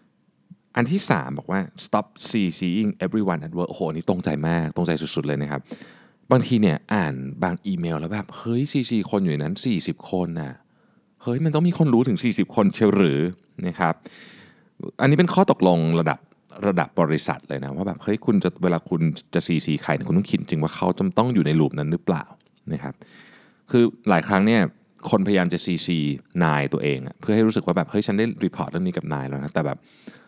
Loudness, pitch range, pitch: -23 LUFS, 80-115 Hz, 90 Hz